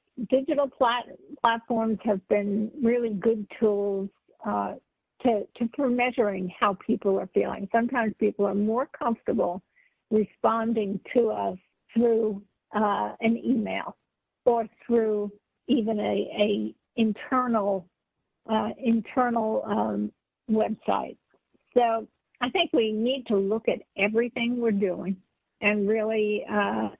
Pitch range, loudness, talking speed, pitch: 205-235 Hz, -26 LUFS, 120 wpm, 220 Hz